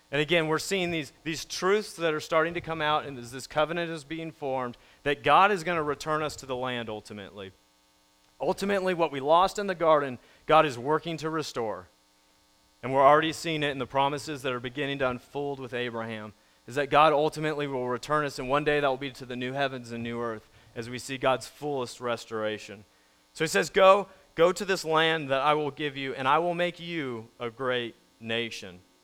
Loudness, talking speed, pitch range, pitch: -27 LUFS, 215 wpm, 120-160 Hz, 140 Hz